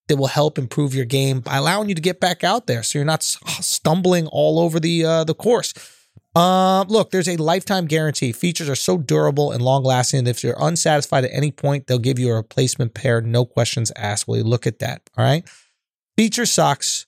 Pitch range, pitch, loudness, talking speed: 125-170 Hz, 145 Hz, -19 LUFS, 220 wpm